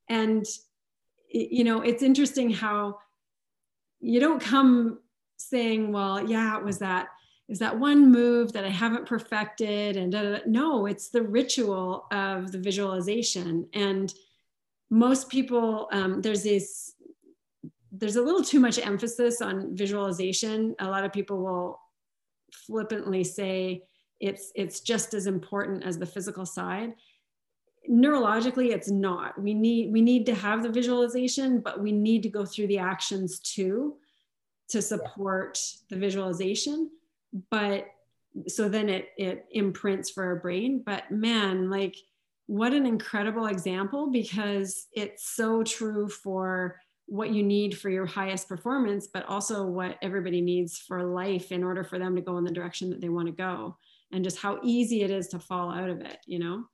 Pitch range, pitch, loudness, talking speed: 190-230 Hz, 205 Hz, -27 LUFS, 160 wpm